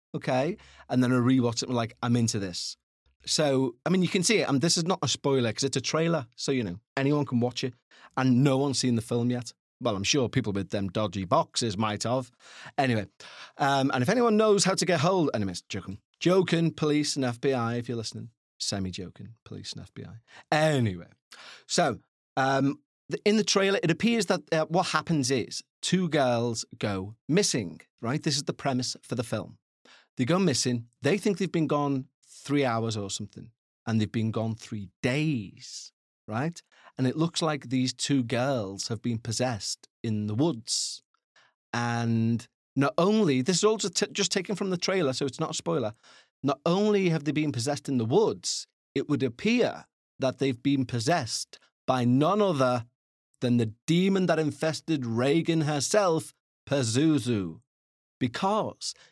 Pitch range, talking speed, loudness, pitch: 115-160 Hz, 185 wpm, -27 LUFS, 135 Hz